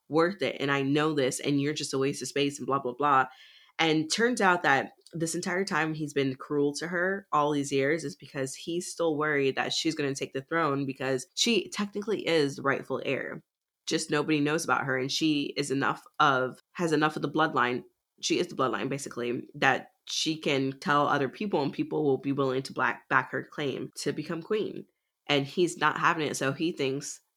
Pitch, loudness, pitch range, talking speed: 145 Hz, -28 LUFS, 135-165 Hz, 215 wpm